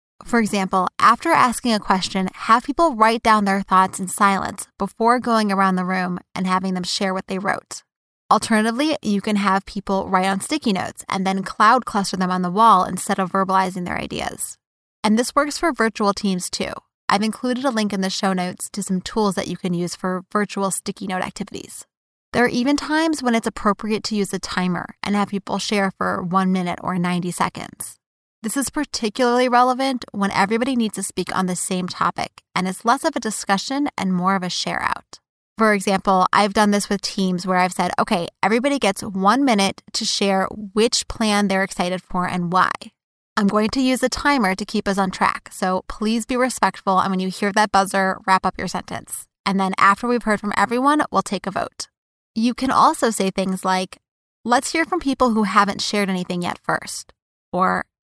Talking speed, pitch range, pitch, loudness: 205 wpm, 190-230 Hz, 200 Hz, -20 LUFS